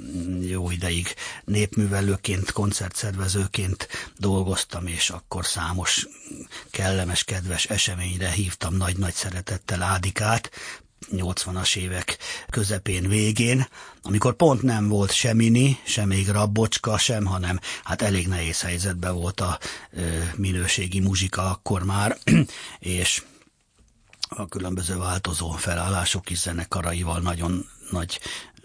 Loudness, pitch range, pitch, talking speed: -24 LUFS, 90-105 Hz, 95 Hz, 105 wpm